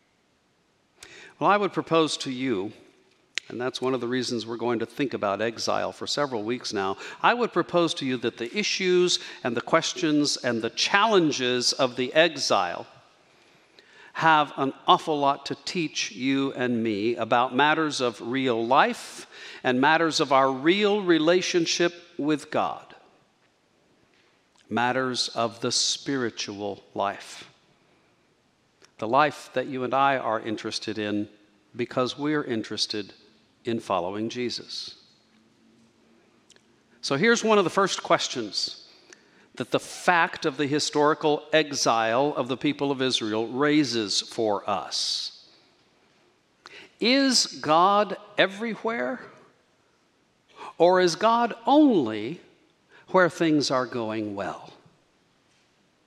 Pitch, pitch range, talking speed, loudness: 135 Hz, 120-165 Hz, 125 wpm, -24 LUFS